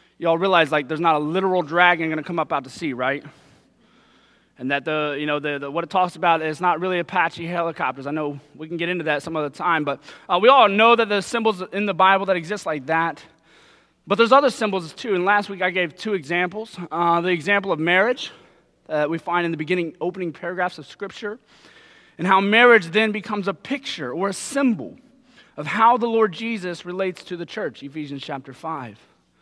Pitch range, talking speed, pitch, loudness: 160-200 Hz, 220 wpm, 180 Hz, -21 LUFS